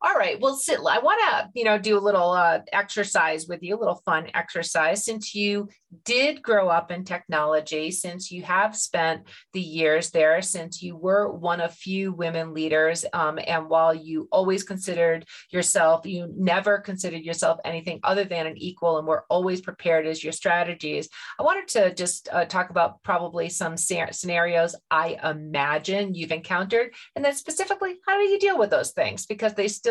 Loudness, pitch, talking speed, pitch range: -24 LUFS, 175 Hz, 185 wpm, 165-200 Hz